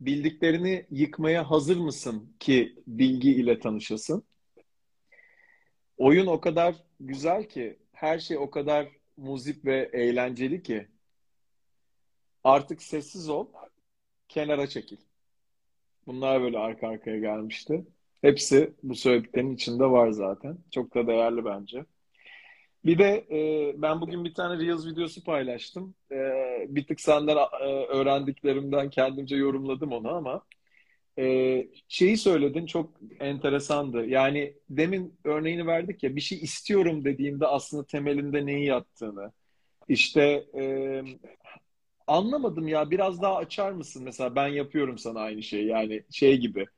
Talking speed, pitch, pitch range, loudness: 115 wpm, 145 Hz, 130-165 Hz, -27 LUFS